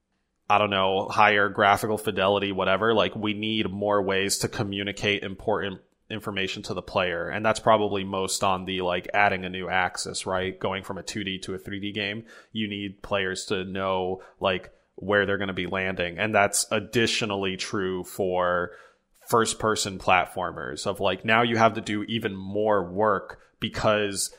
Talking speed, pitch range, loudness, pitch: 170 wpm, 95-105 Hz, -25 LUFS, 100 Hz